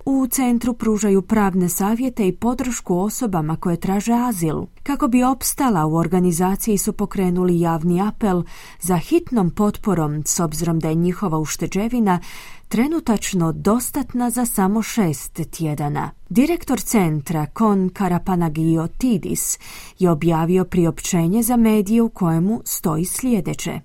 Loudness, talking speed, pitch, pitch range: -19 LUFS, 125 wpm, 190 Hz, 170-230 Hz